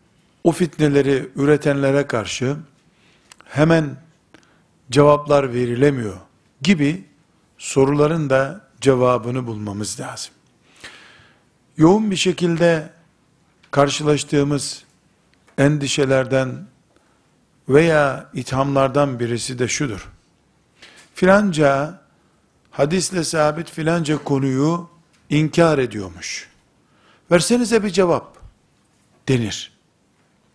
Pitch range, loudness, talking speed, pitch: 135-165 Hz, -18 LUFS, 65 wpm, 145 Hz